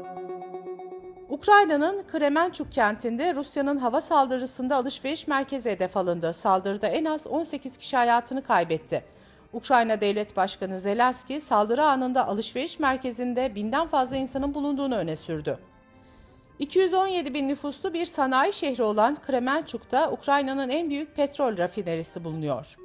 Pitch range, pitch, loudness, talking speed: 215-295 Hz, 265 Hz, -25 LUFS, 120 wpm